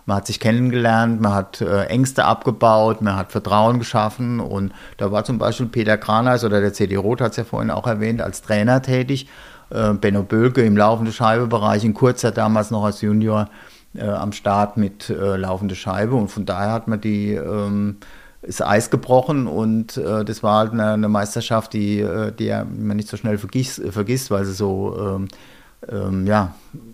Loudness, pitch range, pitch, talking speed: -19 LUFS, 100-115 Hz, 110 Hz, 185 wpm